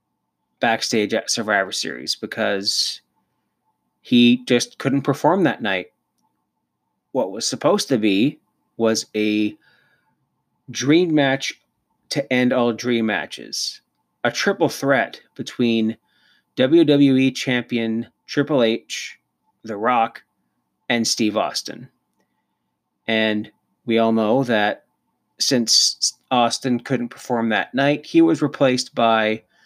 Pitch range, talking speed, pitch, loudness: 110-135 Hz, 105 wpm, 120 Hz, -20 LUFS